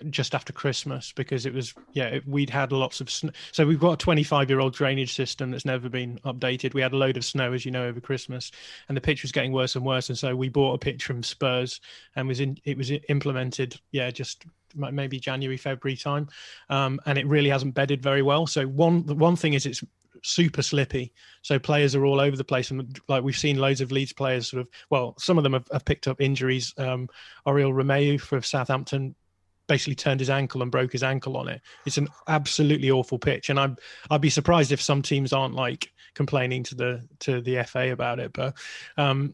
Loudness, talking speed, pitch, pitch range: -26 LUFS, 225 wpm, 135 Hz, 130-145 Hz